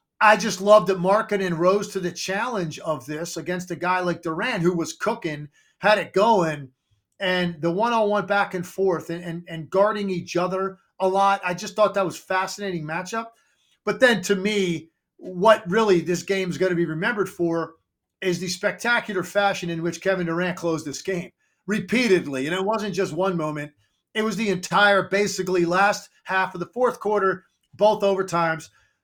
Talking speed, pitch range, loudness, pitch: 185 wpm, 170-205 Hz, -23 LUFS, 185 Hz